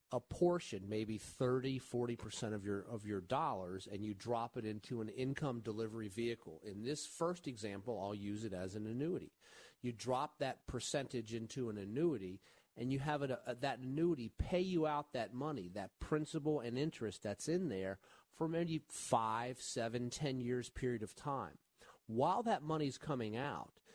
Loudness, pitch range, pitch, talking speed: -41 LUFS, 110-145 Hz, 120 Hz, 175 wpm